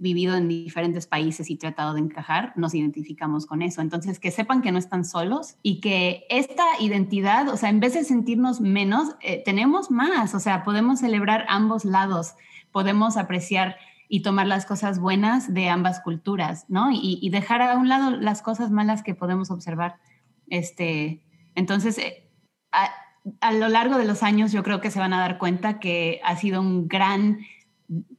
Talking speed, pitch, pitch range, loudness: 180 wpm, 195 Hz, 175-220 Hz, -23 LUFS